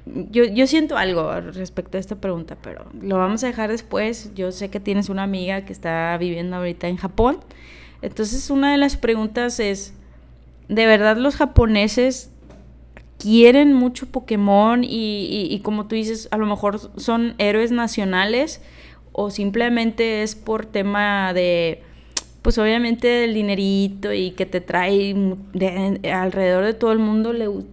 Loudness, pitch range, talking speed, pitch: -20 LUFS, 190-230 Hz, 170 wpm, 210 Hz